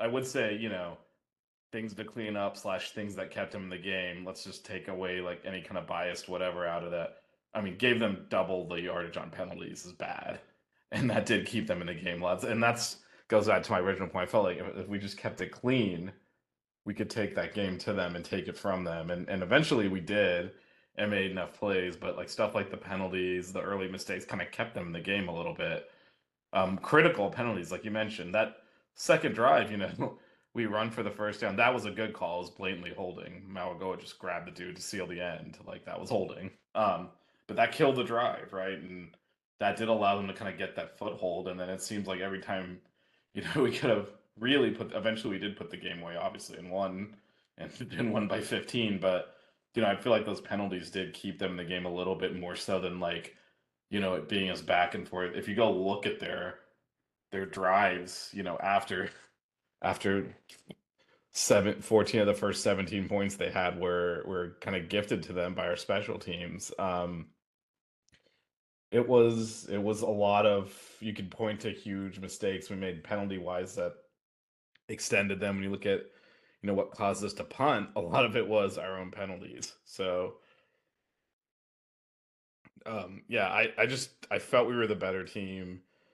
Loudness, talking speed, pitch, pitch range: -32 LUFS, 215 wpm, 95 Hz, 90-105 Hz